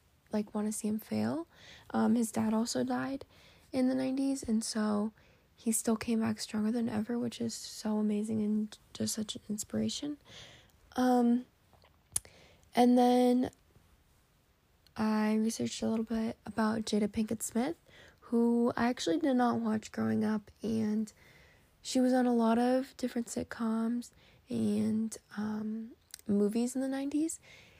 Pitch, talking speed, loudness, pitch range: 225 Hz, 145 wpm, -32 LUFS, 215-245 Hz